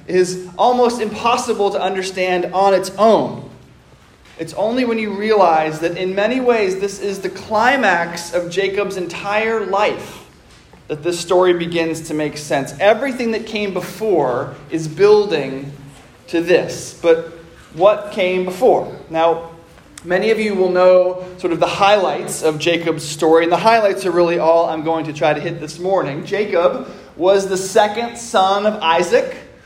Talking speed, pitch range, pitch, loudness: 160 wpm, 165-210 Hz, 185 Hz, -16 LUFS